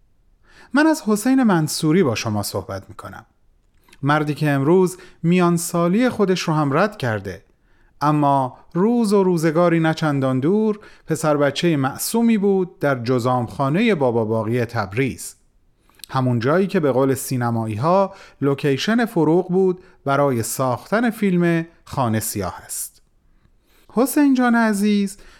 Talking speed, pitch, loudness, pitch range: 130 wpm, 155 Hz, -19 LUFS, 130-195 Hz